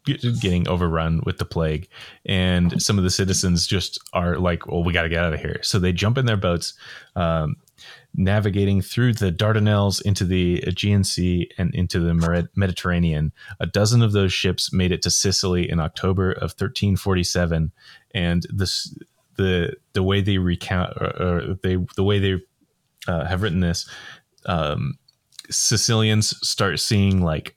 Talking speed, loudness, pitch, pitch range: 165 wpm, -21 LUFS, 95 Hz, 85-100 Hz